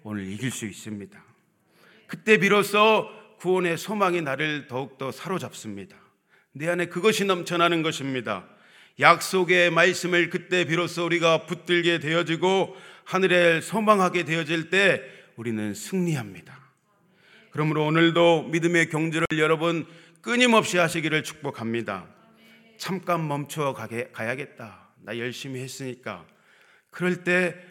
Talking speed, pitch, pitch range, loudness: 290 characters per minute, 170 Hz, 140-180 Hz, -23 LUFS